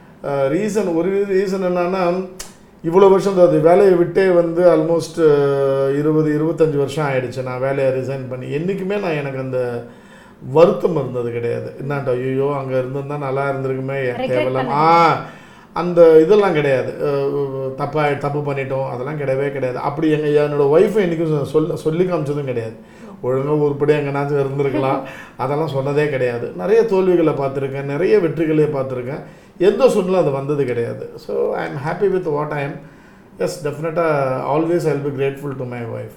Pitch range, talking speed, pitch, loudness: 135-170 Hz, 150 wpm, 145 Hz, -18 LUFS